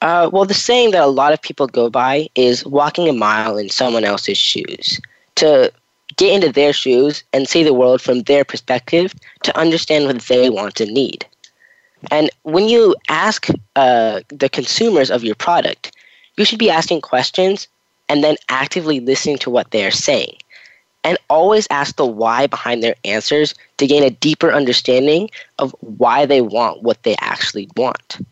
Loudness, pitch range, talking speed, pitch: -15 LUFS, 130-175 Hz, 175 wpm, 145 Hz